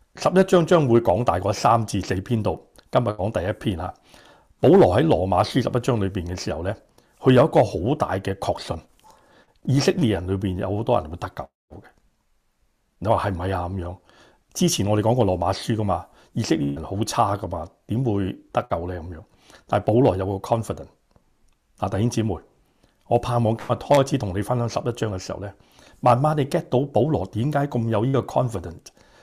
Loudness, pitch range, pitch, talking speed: -22 LUFS, 95-120 Hz, 105 Hz, 320 characters per minute